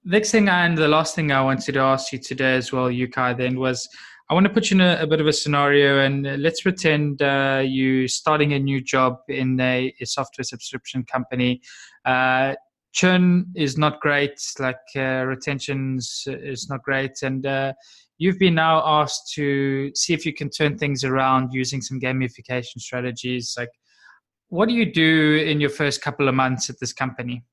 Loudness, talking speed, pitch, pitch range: -21 LUFS, 190 wpm, 135 Hz, 130-150 Hz